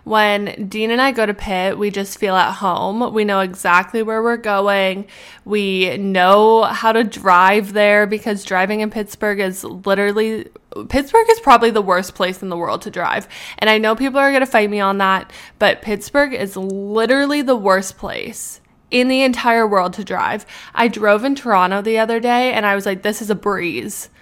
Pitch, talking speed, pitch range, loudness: 210 Hz, 200 wpm, 195-225 Hz, -16 LUFS